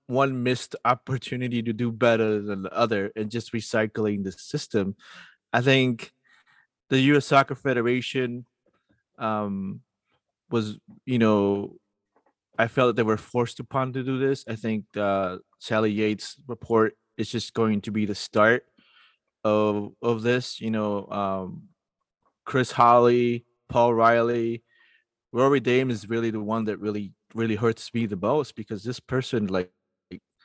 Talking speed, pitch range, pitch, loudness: 145 wpm, 105-125 Hz, 115 Hz, -25 LUFS